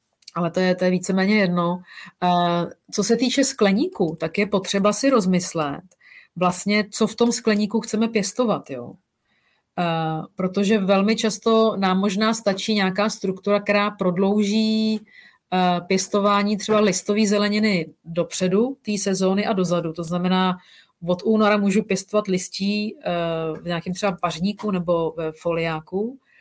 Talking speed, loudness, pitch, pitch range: 125 wpm, -21 LUFS, 195 Hz, 180-210 Hz